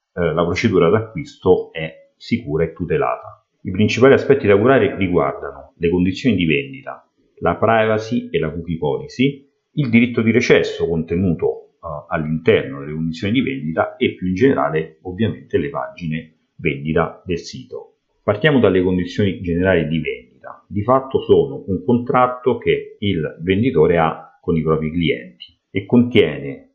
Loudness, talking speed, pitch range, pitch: -18 LUFS, 145 wpm, 85-135 Hz, 110 Hz